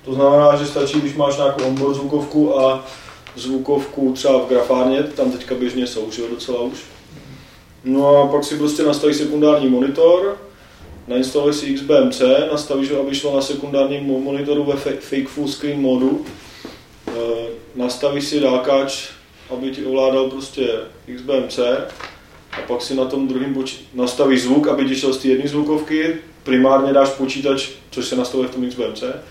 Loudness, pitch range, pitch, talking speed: -18 LUFS, 130-145 Hz, 135 Hz, 160 wpm